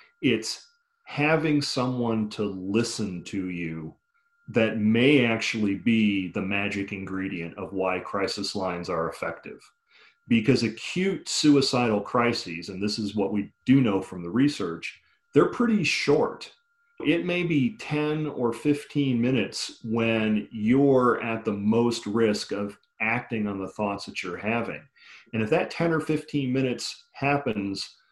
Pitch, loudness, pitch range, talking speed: 115 Hz, -26 LUFS, 100-140 Hz, 140 wpm